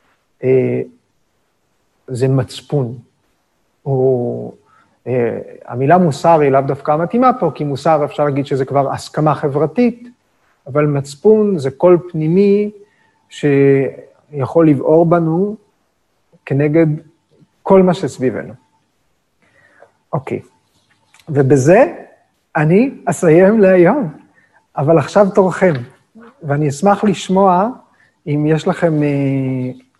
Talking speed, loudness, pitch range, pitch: 90 wpm, -14 LUFS, 140-185 Hz, 155 Hz